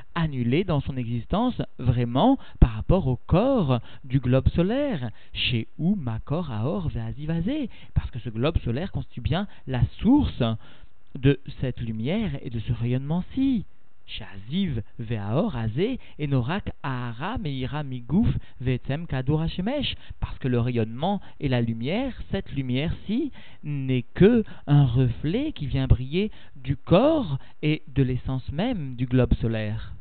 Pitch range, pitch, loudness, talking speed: 120-180 Hz, 135 Hz, -26 LUFS, 130 wpm